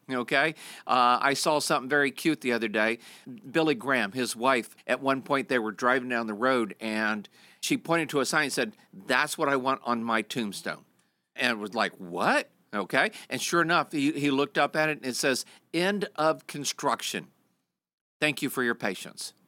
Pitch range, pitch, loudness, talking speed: 120-155 Hz, 135 Hz, -27 LUFS, 195 wpm